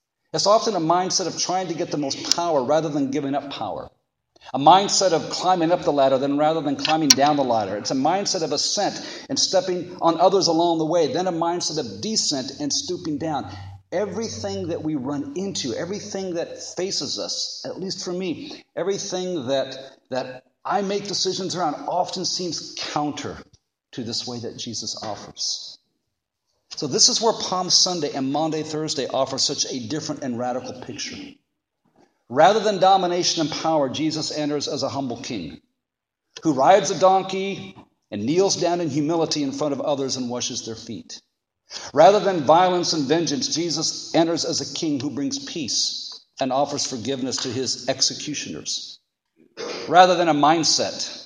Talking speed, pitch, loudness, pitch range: 170 wpm, 165 Hz, -22 LUFS, 145-185 Hz